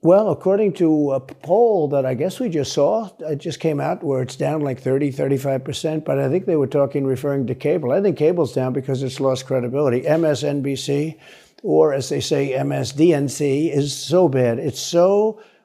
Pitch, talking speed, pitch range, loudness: 145 Hz, 190 wpm, 135-165 Hz, -20 LUFS